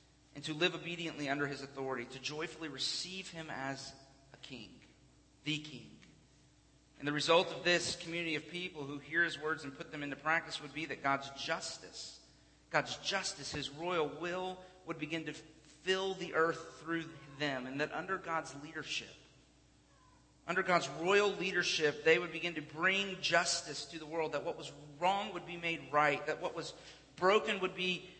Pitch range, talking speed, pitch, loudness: 145-175 Hz, 175 wpm, 160 Hz, -36 LUFS